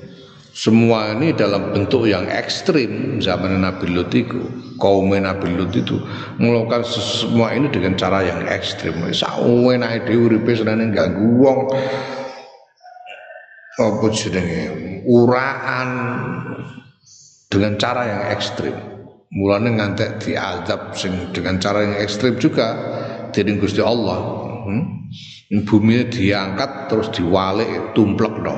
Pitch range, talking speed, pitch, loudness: 100-125 Hz, 100 wpm, 110 Hz, -18 LUFS